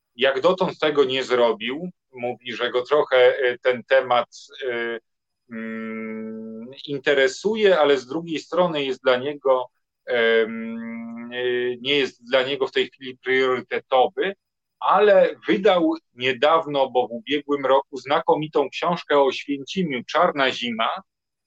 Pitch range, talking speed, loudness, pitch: 120-150 Hz, 115 wpm, -21 LUFS, 130 Hz